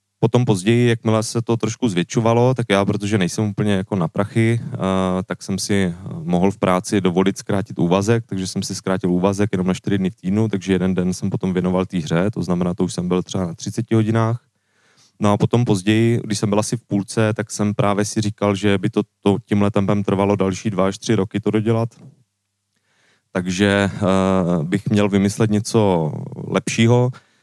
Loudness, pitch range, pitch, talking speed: -19 LUFS, 95-110 Hz, 100 Hz, 195 wpm